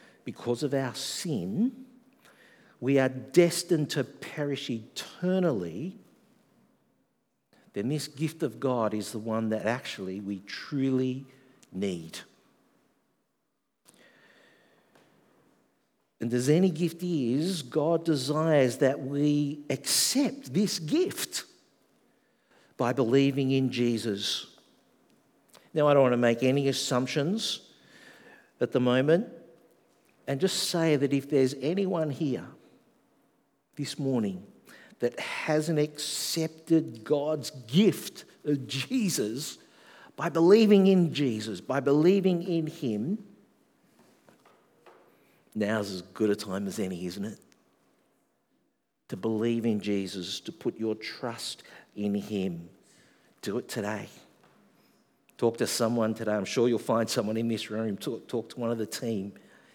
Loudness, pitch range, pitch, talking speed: -28 LUFS, 115-165 Hz, 140 Hz, 115 wpm